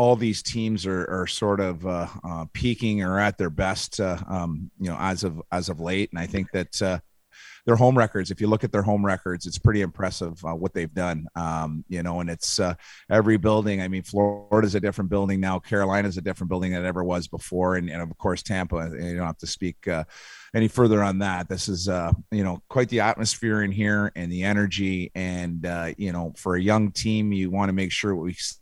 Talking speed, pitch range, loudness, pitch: 240 wpm, 90-105 Hz, -25 LUFS, 95 Hz